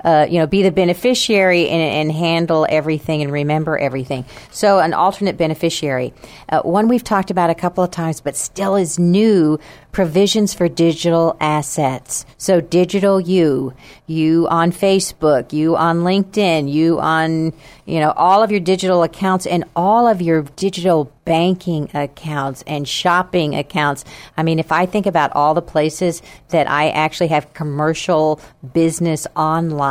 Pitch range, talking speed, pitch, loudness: 150-180 Hz, 155 wpm, 165 Hz, -16 LUFS